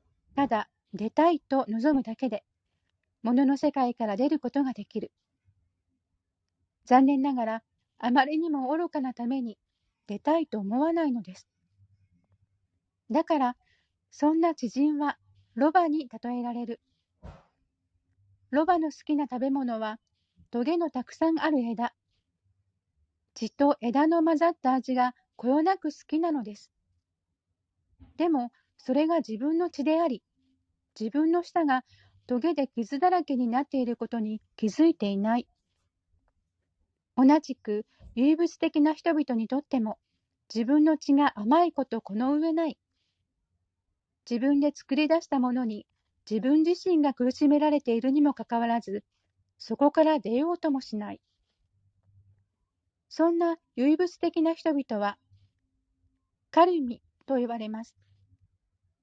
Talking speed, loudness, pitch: 240 characters per minute, -27 LUFS, 240 Hz